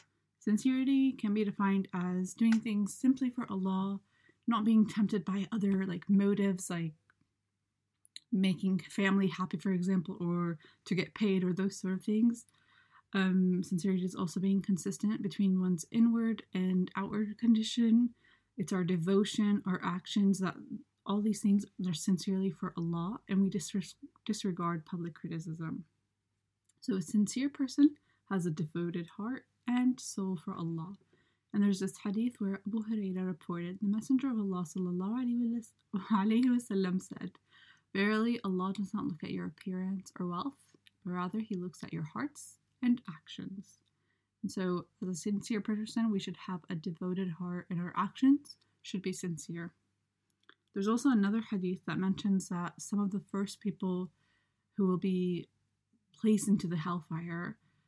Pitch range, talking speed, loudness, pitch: 180-215 Hz, 150 wpm, -34 LUFS, 195 Hz